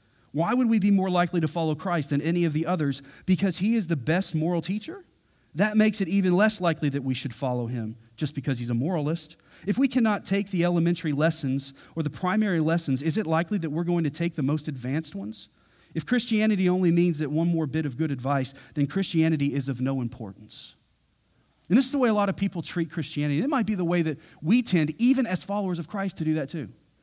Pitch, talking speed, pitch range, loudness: 165 Hz, 235 wpm, 140-190 Hz, -25 LUFS